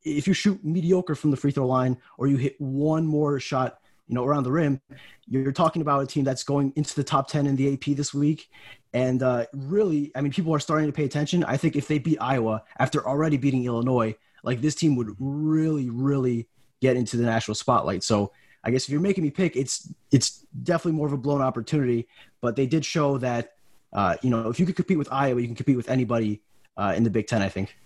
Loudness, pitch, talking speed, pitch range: -25 LUFS, 140 Hz, 235 wpm, 125-150 Hz